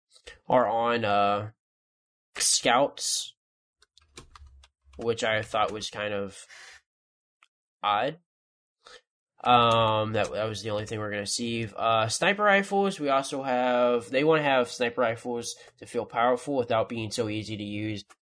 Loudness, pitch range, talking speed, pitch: -26 LUFS, 105-125 Hz, 140 wpm, 115 Hz